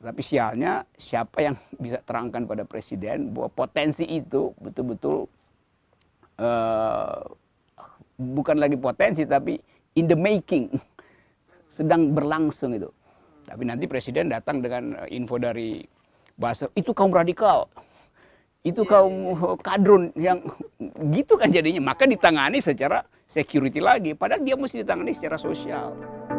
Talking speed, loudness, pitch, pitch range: 120 wpm, -23 LUFS, 155 Hz, 125-185 Hz